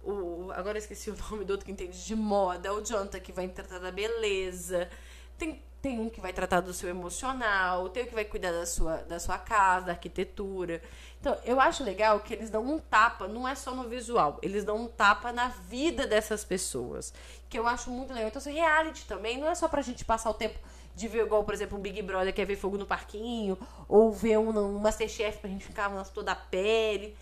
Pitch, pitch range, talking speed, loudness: 210 Hz, 185-225 Hz, 230 wpm, -31 LUFS